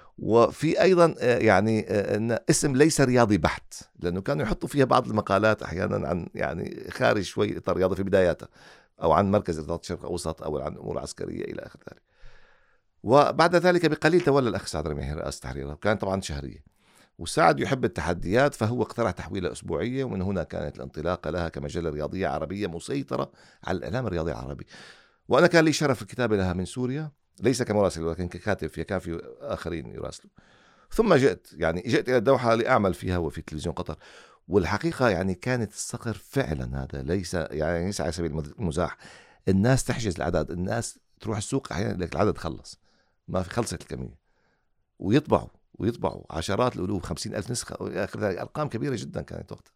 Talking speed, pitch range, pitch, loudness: 160 wpm, 85-125 Hz, 100 Hz, -26 LUFS